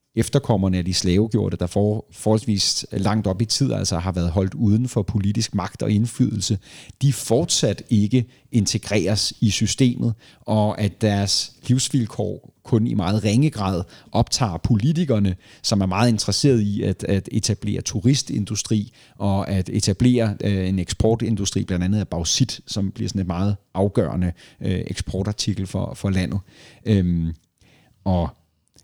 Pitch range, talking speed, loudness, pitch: 95-115 Hz, 145 wpm, -21 LUFS, 105 Hz